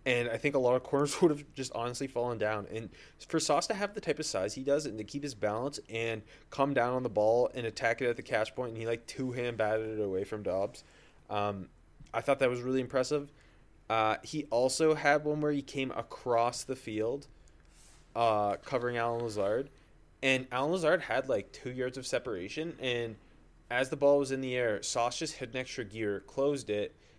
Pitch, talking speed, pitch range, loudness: 125 Hz, 220 wpm, 110-135 Hz, -32 LUFS